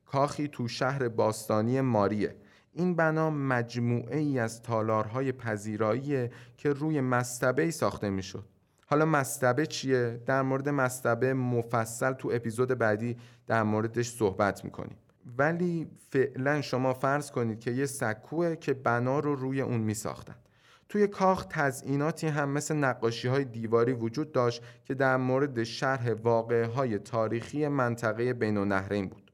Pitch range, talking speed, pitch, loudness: 115-140 Hz, 140 wpm, 125 Hz, -29 LUFS